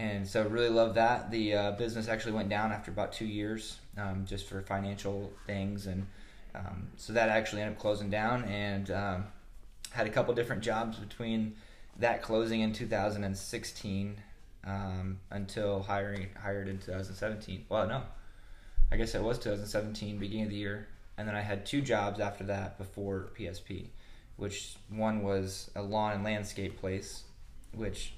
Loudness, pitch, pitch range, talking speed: -35 LUFS, 100 Hz, 100-110 Hz, 165 wpm